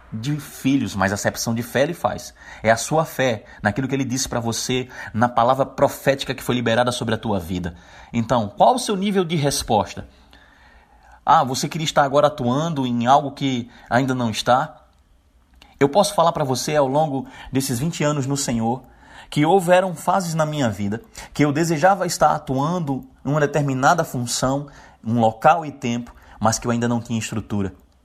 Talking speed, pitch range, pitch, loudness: 185 wpm, 115-150 Hz, 130 Hz, -21 LUFS